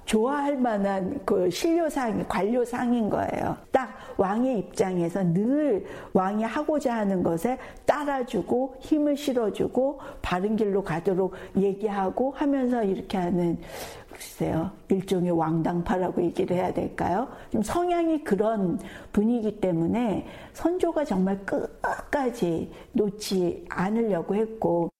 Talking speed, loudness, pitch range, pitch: 260 characters per minute, -26 LUFS, 190-260 Hz, 215 Hz